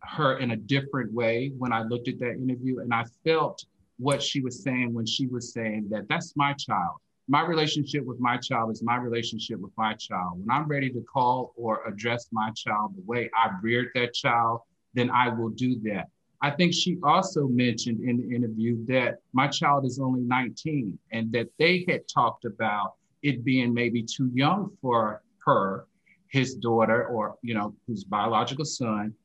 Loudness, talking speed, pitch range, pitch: -27 LUFS, 190 wpm, 115-140 Hz, 125 Hz